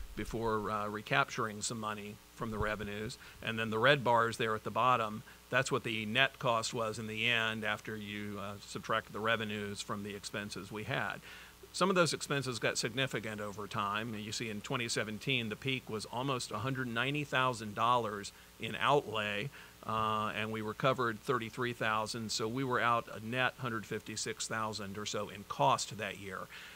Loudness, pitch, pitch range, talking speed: -35 LUFS, 110 Hz, 105-125 Hz, 165 wpm